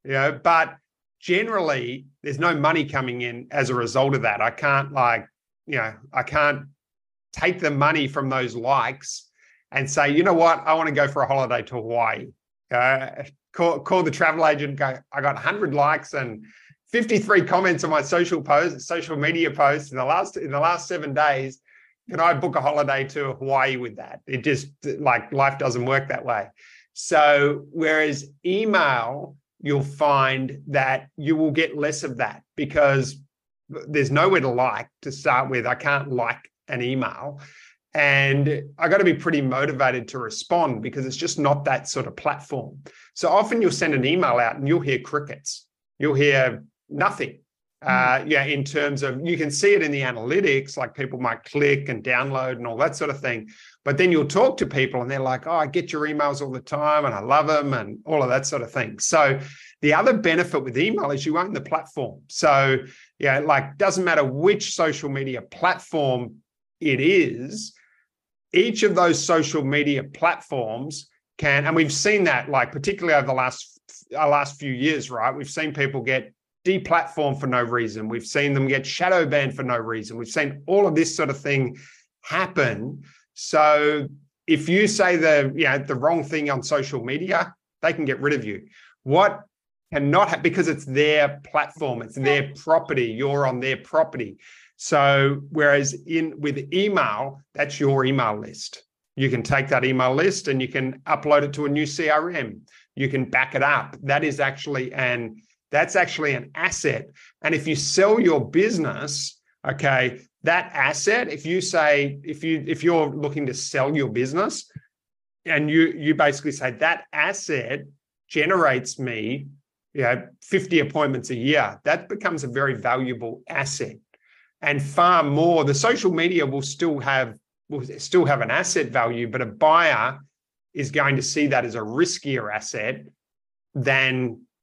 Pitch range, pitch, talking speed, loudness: 130-155 Hz, 145 Hz, 180 wpm, -22 LUFS